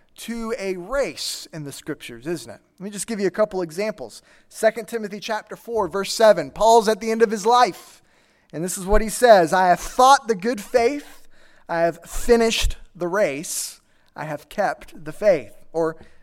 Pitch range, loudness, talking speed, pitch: 175-230 Hz, -21 LUFS, 190 wpm, 210 Hz